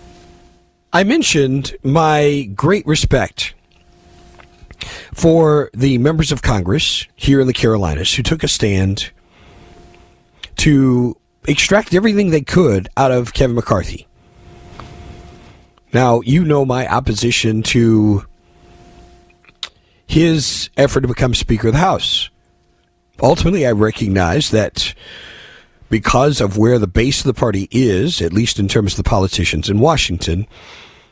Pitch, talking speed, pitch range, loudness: 115 Hz, 120 wpm, 95-140 Hz, -14 LUFS